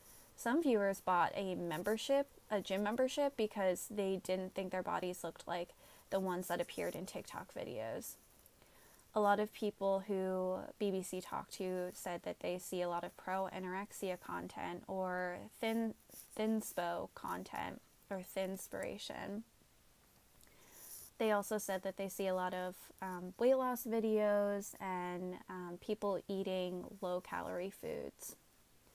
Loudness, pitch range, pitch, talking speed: -40 LUFS, 180-210 Hz, 190 Hz, 140 wpm